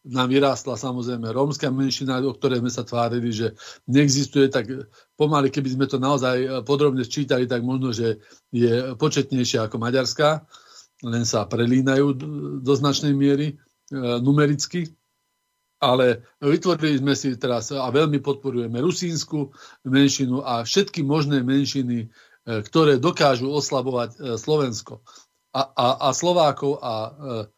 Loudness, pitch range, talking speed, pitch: -22 LUFS, 125-145 Hz, 135 wpm, 135 Hz